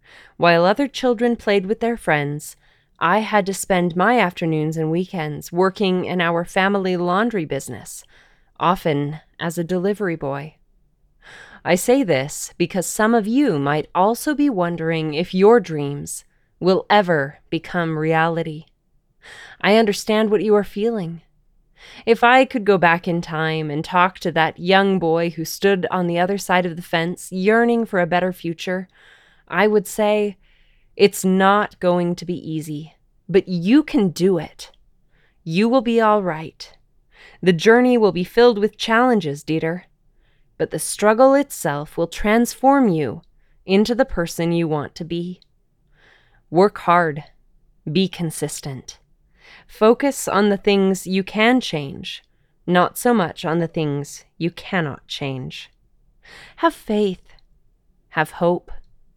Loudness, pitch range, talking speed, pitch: -19 LUFS, 160-210 Hz, 145 wpm, 180 Hz